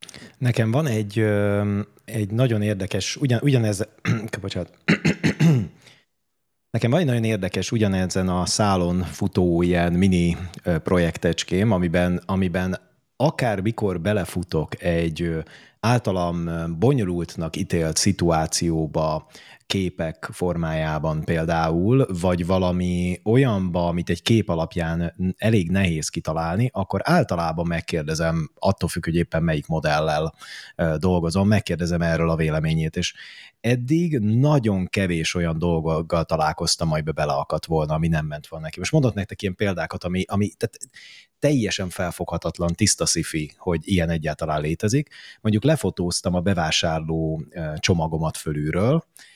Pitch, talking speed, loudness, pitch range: 90 Hz, 120 wpm, -23 LUFS, 80-105 Hz